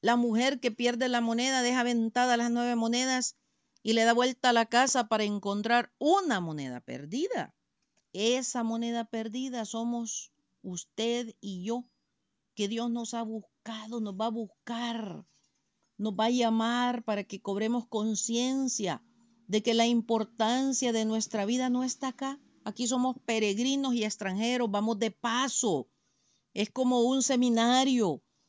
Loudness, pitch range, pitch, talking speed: -29 LUFS, 220-245 Hz, 235 Hz, 145 wpm